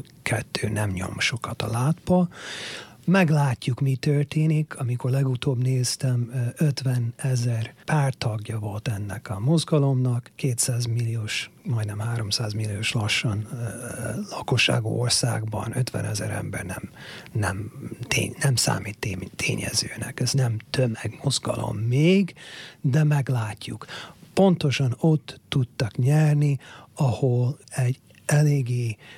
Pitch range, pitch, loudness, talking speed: 110-140 Hz, 125 Hz, -25 LUFS, 105 wpm